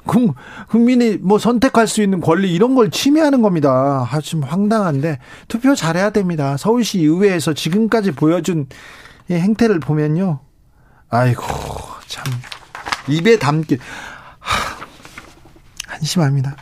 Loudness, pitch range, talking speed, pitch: -16 LUFS, 150-220 Hz, 255 characters per minute, 175 Hz